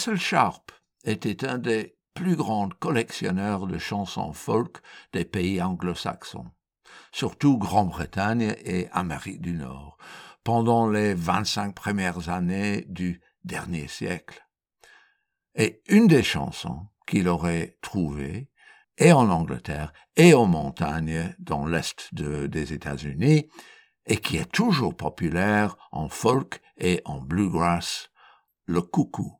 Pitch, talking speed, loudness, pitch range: 95 Hz, 120 wpm, -25 LUFS, 85-115 Hz